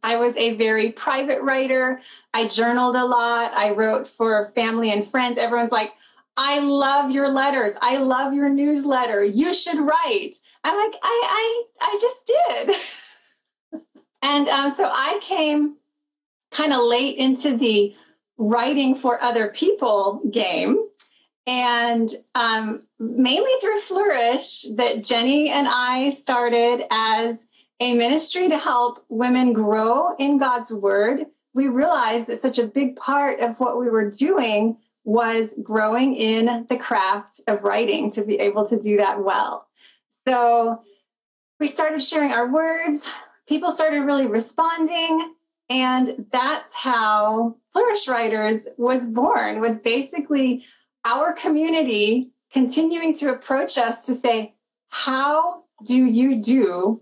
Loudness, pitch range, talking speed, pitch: -20 LUFS, 230-295 Hz, 135 wpm, 255 Hz